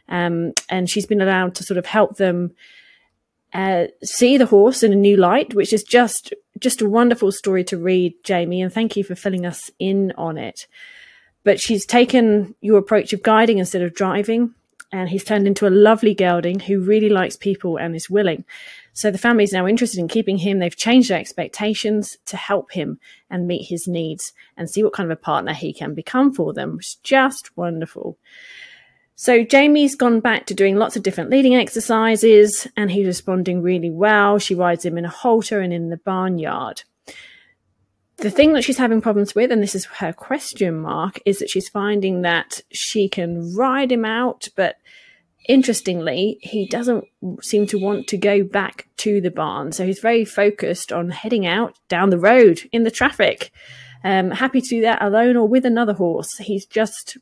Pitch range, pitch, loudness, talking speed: 185-230 Hz, 205 Hz, -18 LUFS, 190 wpm